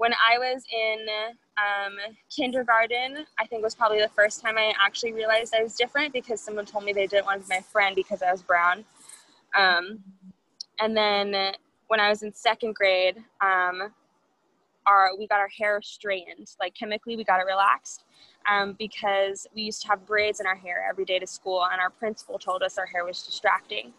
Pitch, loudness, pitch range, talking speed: 210 Hz, -25 LUFS, 195-225 Hz, 200 wpm